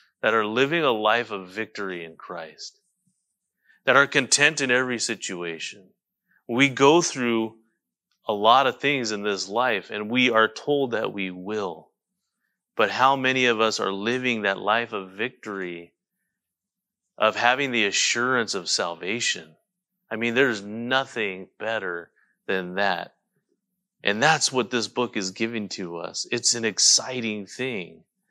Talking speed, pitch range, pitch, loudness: 145 wpm, 105-135 Hz, 120 Hz, -23 LUFS